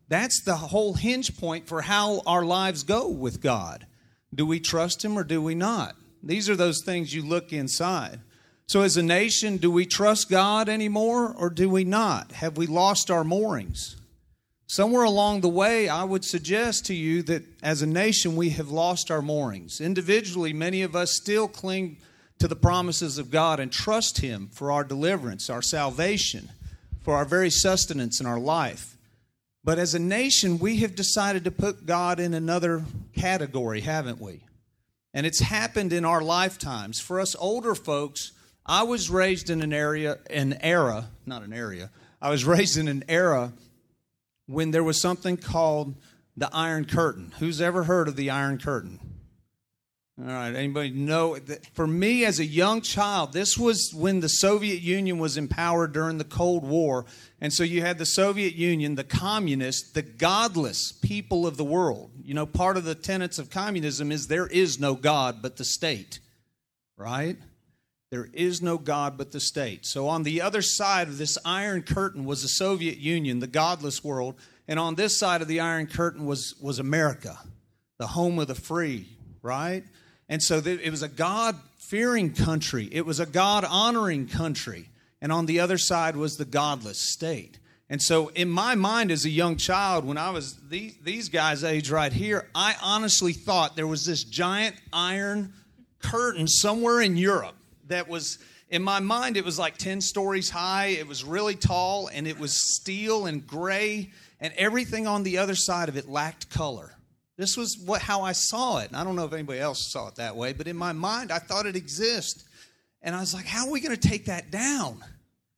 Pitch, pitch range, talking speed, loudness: 165 Hz, 145-190 Hz, 190 wpm, -25 LUFS